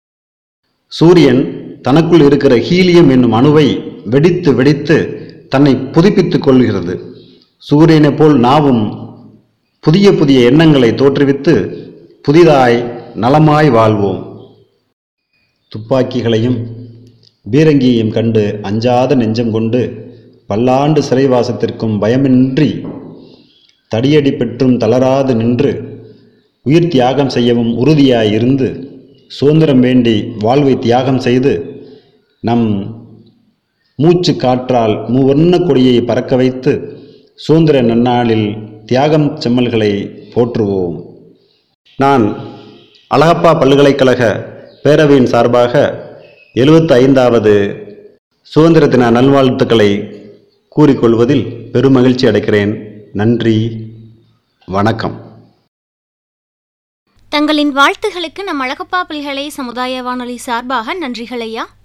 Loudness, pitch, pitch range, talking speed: -11 LUFS, 125 Hz, 115-150 Hz, 75 wpm